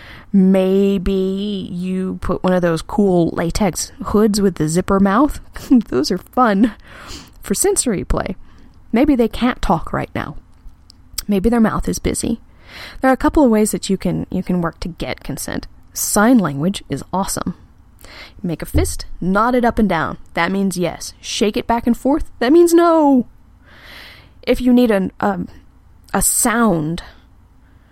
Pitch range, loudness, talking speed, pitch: 170-235 Hz, -17 LUFS, 160 wpm, 195 Hz